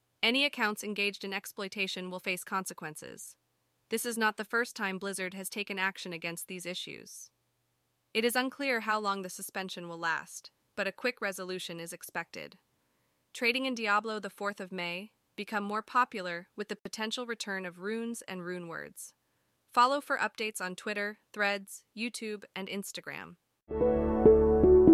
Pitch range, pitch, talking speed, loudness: 185-220 Hz, 200 Hz, 155 wpm, -32 LUFS